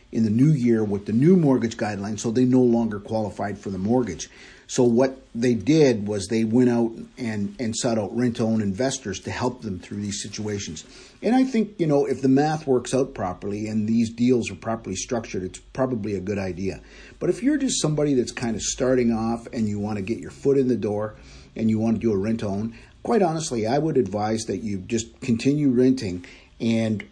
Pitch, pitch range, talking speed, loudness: 115 Hz, 105-130 Hz, 215 wpm, -23 LUFS